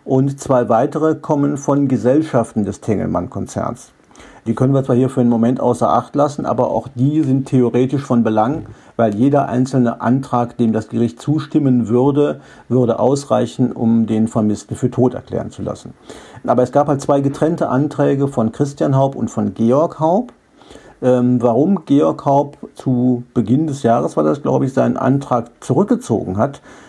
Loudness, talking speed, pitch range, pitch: -16 LUFS, 165 wpm, 115-140 Hz, 125 Hz